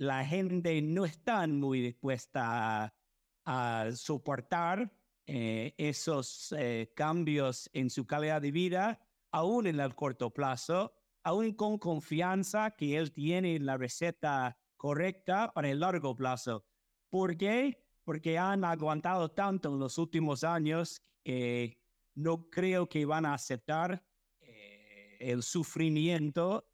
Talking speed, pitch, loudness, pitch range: 125 wpm, 155 Hz, -34 LUFS, 130-175 Hz